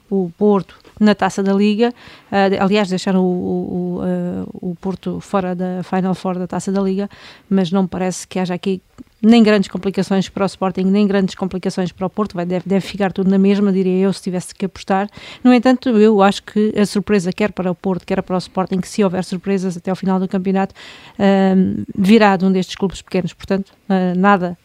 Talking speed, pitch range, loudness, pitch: 215 wpm, 185-200 Hz, -17 LUFS, 195 Hz